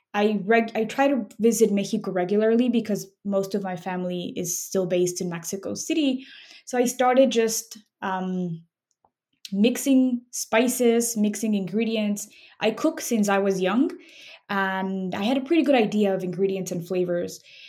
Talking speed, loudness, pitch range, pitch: 155 wpm, -24 LUFS, 190-245 Hz, 215 Hz